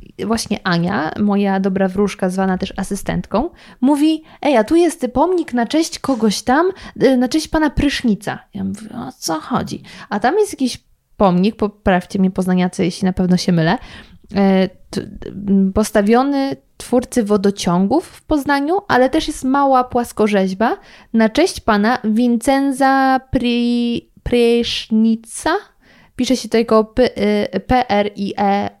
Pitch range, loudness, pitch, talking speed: 195-265 Hz, -17 LUFS, 225 Hz, 130 wpm